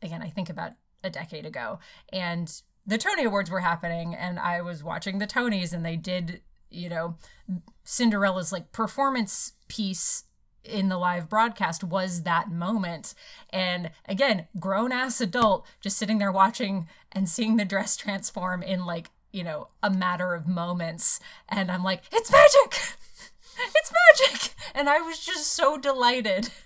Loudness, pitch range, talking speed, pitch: -25 LUFS, 180-240 Hz, 160 wpm, 195 Hz